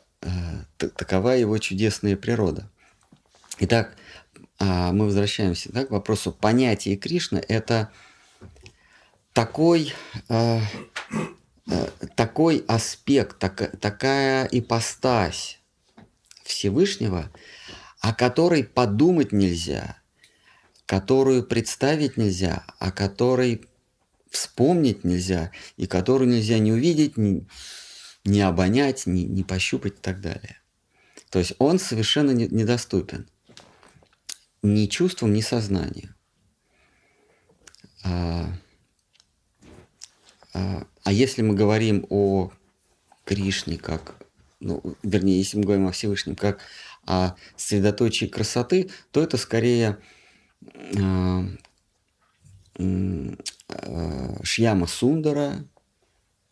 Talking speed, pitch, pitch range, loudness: 90 wpm, 105 Hz, 95-120 Hz, -23 LUFS